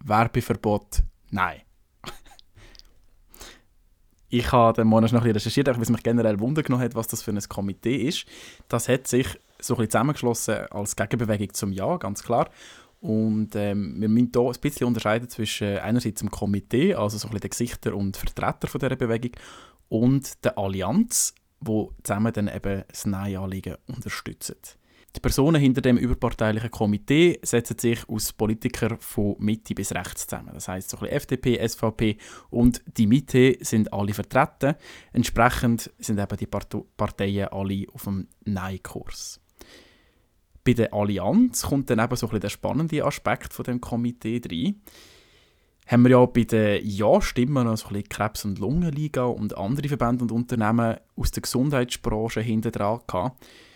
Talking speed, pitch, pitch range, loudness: 160 wpm, 115 Hz, 105-125 Hz, -24 LUFS